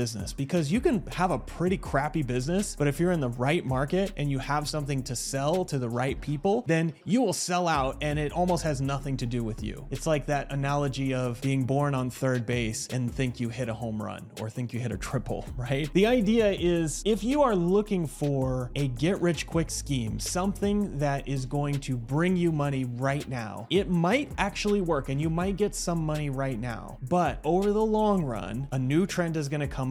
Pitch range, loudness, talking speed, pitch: 130-175 Hz, -28 LUFS, 220 wpm, 145 Hz